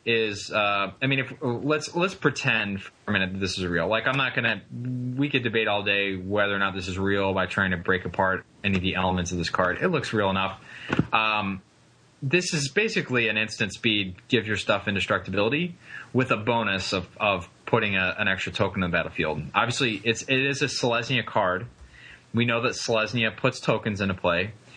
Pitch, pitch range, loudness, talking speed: 110 Hz, 95-130 Hz, -25 LUFS, 205 wpm